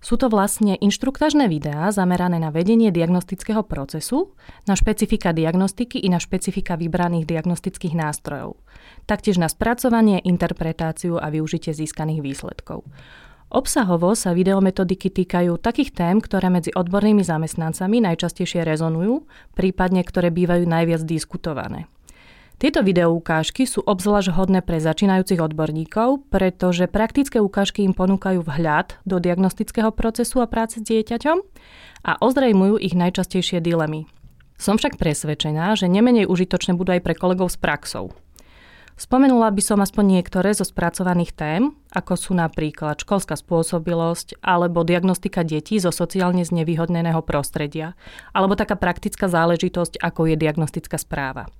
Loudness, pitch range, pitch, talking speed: -20 LUFS, 170-205 Hz, 180 Hz, 130 wpm